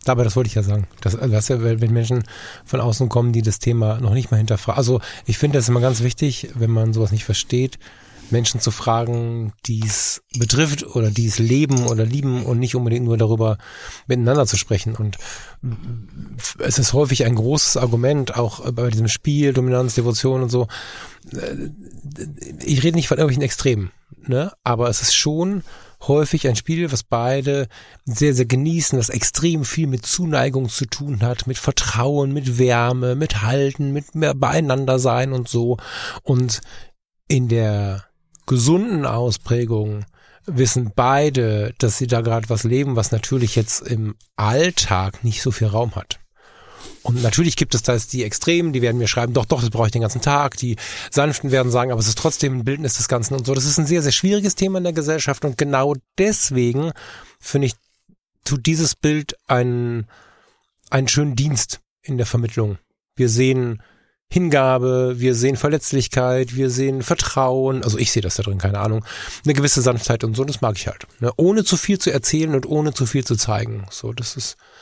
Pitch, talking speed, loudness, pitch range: 125 Hz, 185 wpm, -19 LUFS, 115-140 Hz